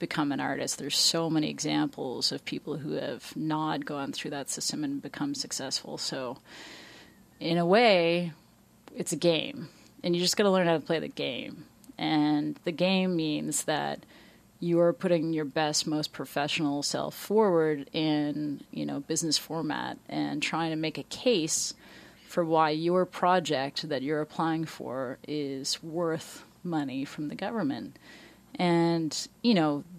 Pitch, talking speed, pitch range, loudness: 160 Hz, 155 wpm, 150-175 Hz, -29 LUFS